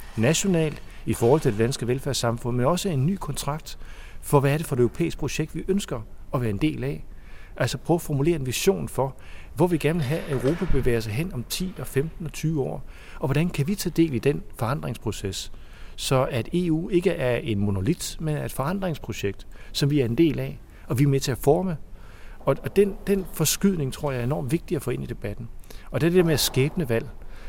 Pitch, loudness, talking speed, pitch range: 140 Hz, -25 LUFS, 230 wpm, 115-165 Hz